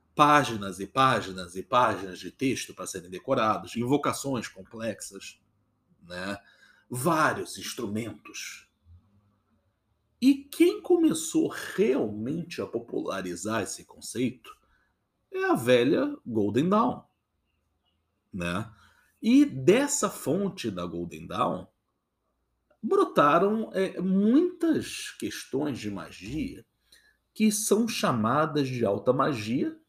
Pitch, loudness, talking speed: 130 Hz, -27 LUFS, 95 wpm